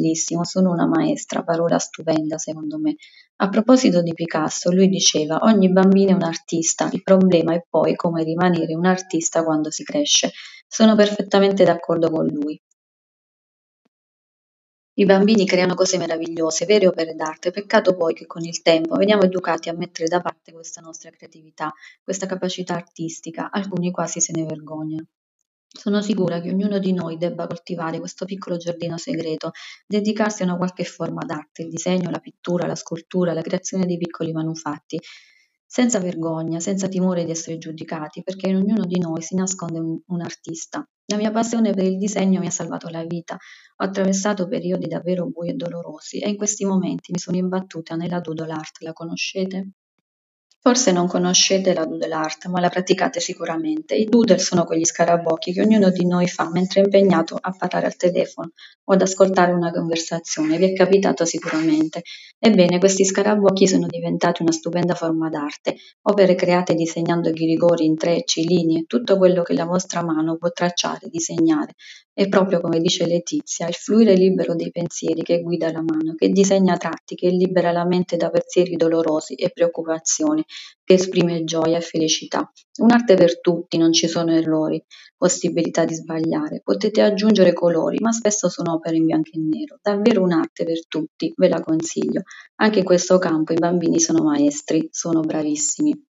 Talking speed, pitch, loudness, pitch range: 170 wpm, 175 Hz, -20 LUFS, 165-190 Hz